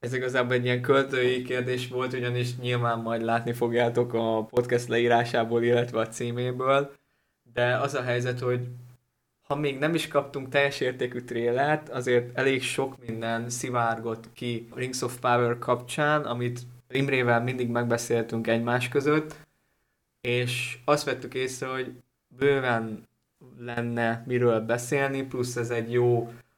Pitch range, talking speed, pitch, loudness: 120-130 Hz, 140 wpm, 125 Hz, -27 LUFS